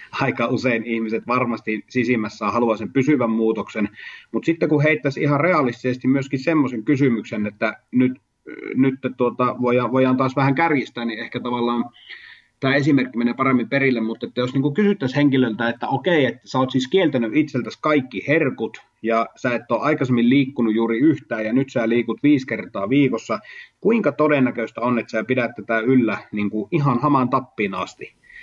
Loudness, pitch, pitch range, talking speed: -20 LUFS, 125 Hz, 115-140 Hz, 165 wpm